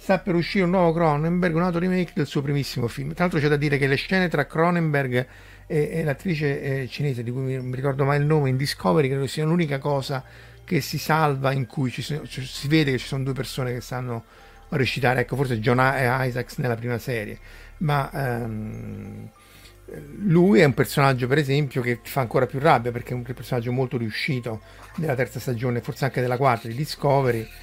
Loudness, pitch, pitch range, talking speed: -23 LUFS, 135 Hz, 120-150 Hz, 210 wpm